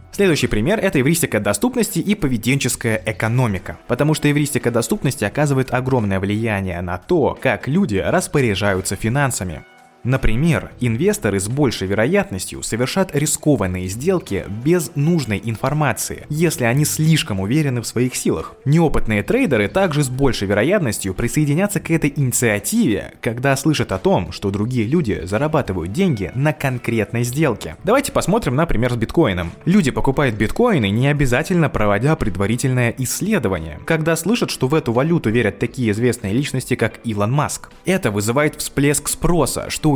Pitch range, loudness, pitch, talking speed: 110-155 Hz, -18 LUFS, 125 Hz, 140 wpm